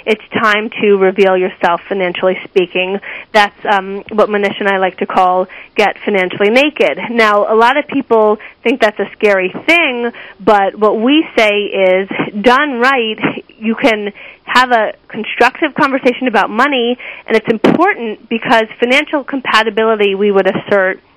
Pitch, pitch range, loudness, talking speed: 220 Hz, 200-250 Hz, -12 LUFS, 150 wpm